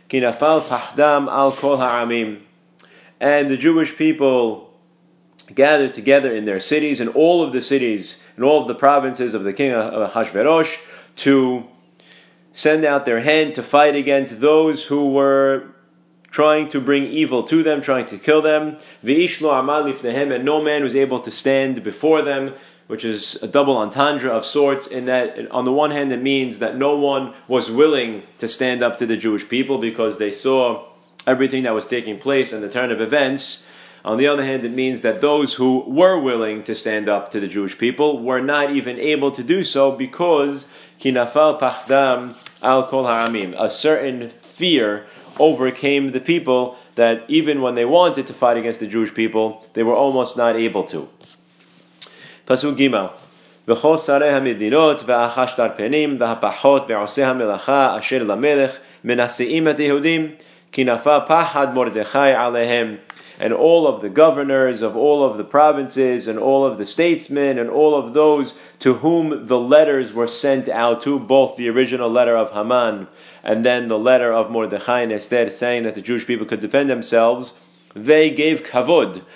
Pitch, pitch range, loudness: 135 Hz, 120-145 Hz, -17 LUFS